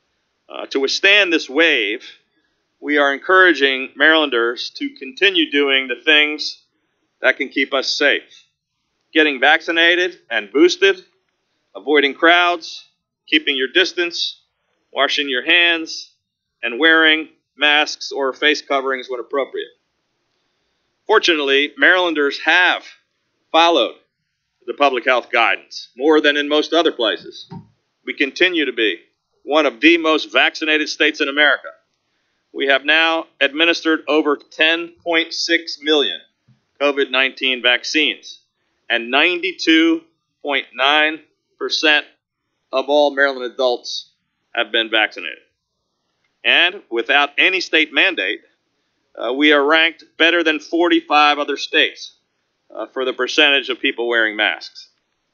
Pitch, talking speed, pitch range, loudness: 155 Hz, 115 wpm, 140-170 Hz, -15 LUFS